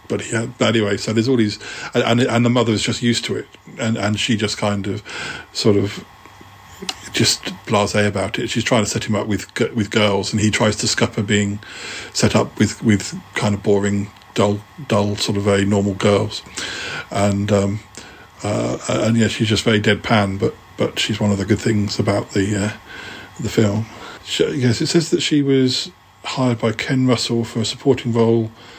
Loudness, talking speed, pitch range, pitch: -19 LUFS, 195 wpm, 100-115 Hz, 110 Hz